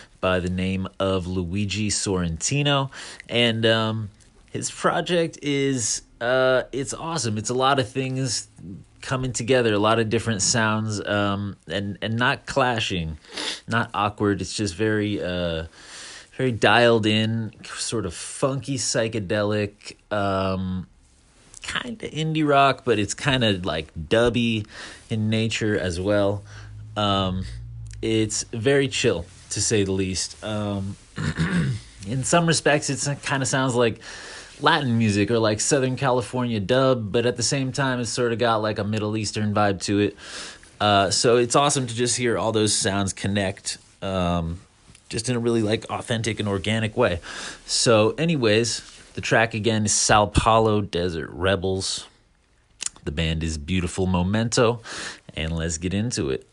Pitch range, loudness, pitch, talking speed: 100-125 Hz, -23 LUFS, 110 Hz, 150 wpm